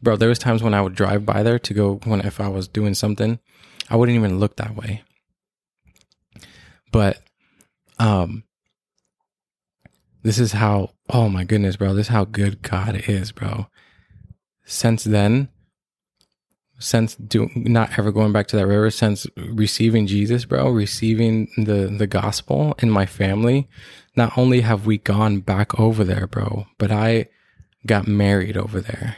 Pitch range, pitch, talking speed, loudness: 100-115 Hz, 105 Hz, 160 wpm, -20 LUFS